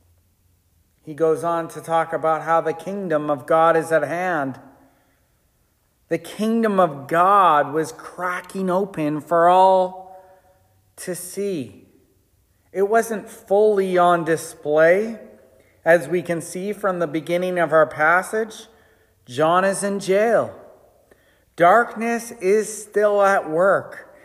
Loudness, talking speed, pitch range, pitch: -20 LUFS, 120 wpm, 155-195 Hz, 170 Hz